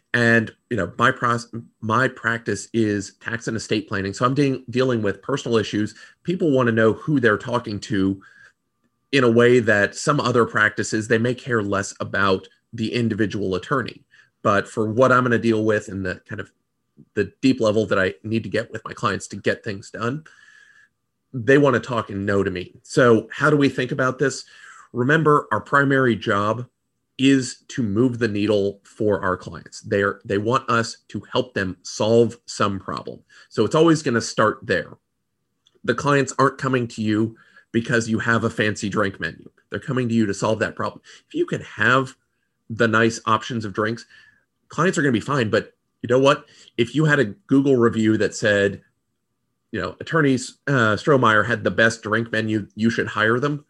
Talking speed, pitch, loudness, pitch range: 195 wpm, 115 Hz, -21 LUFS, 105-130 Hz